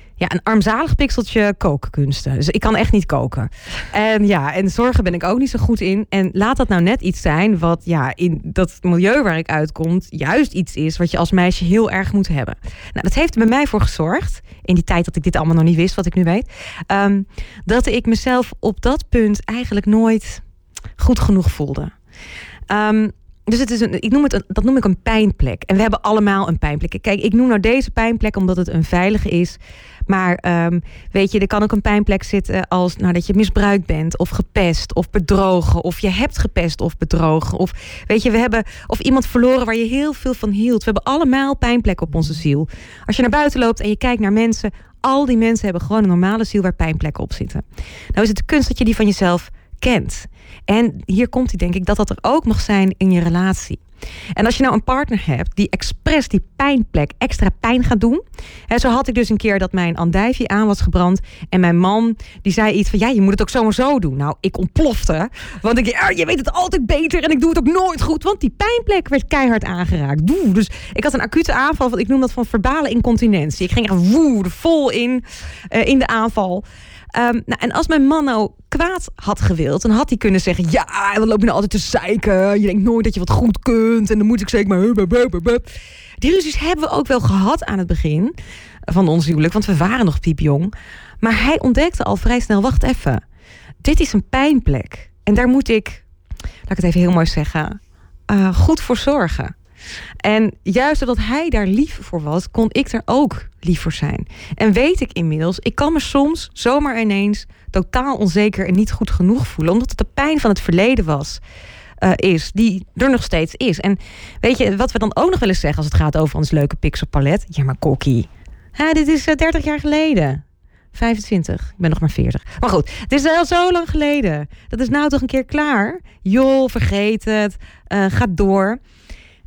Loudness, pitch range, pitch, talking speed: -16 LUFS, 175-245 Hz, 210 Hz, 220 wpm